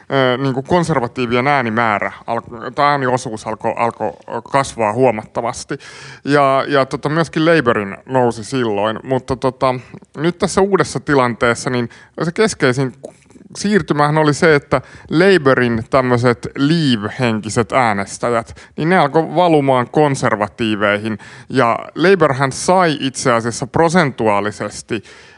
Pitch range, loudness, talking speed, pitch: 115-150 Hz, -16 LUFS, 105 wpm, 130 Hz